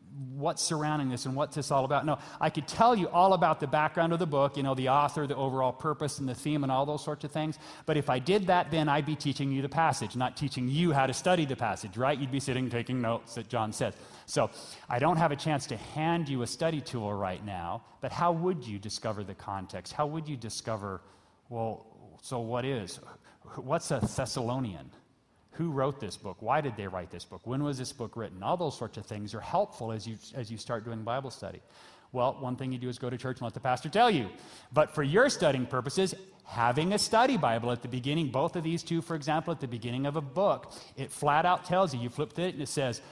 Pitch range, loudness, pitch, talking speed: 115-155 Hz, -31 LUFS, 135 Hz, 245 wpm